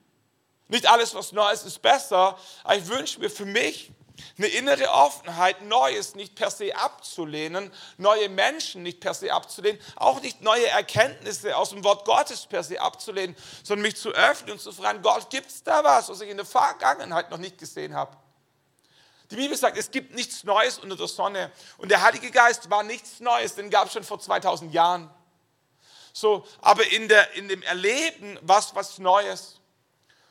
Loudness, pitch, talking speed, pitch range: -23 LUFS, 205 Hz, 180 wpm, 185-230 Hz